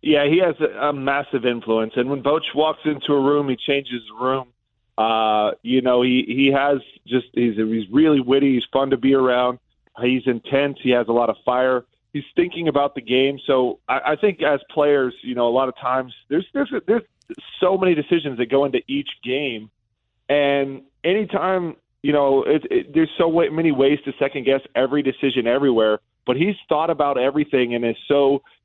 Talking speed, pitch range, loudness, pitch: 195 wpm, 125-150 Hz, -20 LUFS, 135 Hz